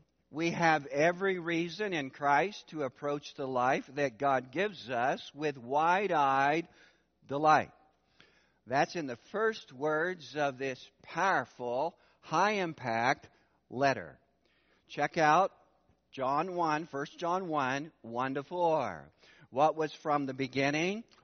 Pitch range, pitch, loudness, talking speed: 135-170 Hz, 150 Hz, -32 LUFS, 120 wpm